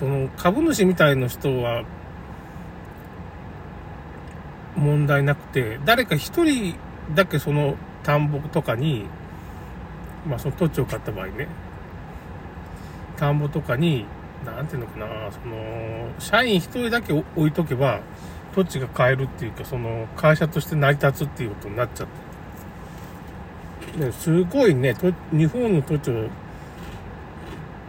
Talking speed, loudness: 215 characters per minute, -23 LUFS